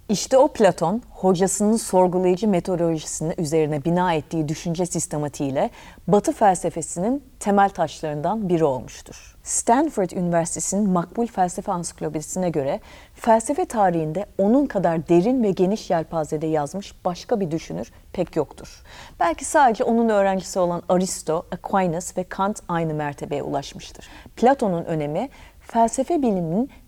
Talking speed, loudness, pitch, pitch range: 120 wpm, -22 LUFS, 185 Hz, 165-210 Hz